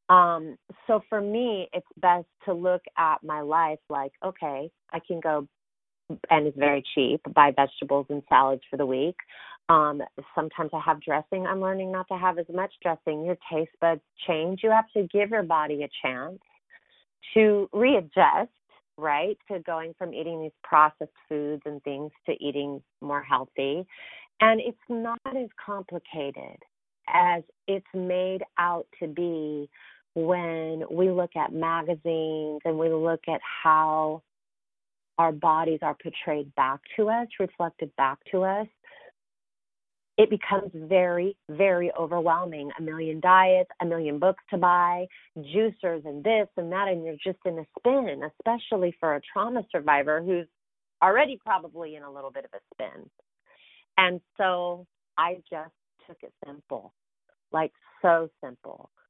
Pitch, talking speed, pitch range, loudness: 170 Hz, 150 wpm, 155-190 Hz, -26 LUFS